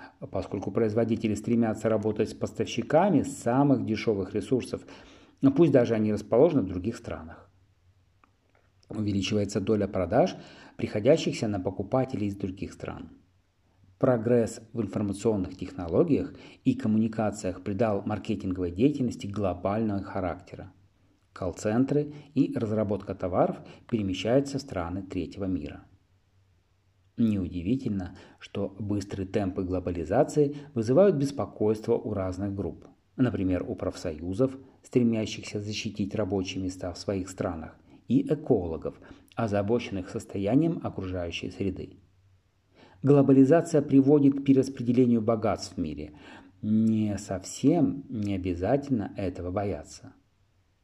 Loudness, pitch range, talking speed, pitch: -27 LUFS, 95-120 Hz, 100 wpm, 105 Hz